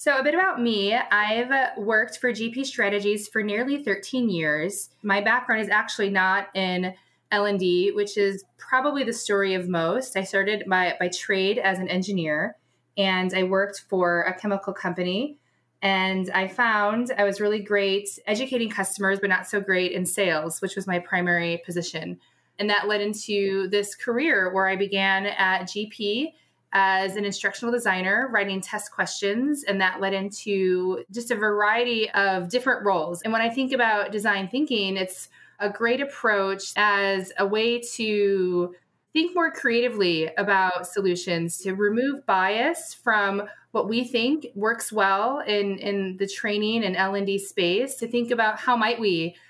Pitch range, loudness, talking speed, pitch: 190-225 Hz, -24 LUFS, 165 wpm, 200 Hz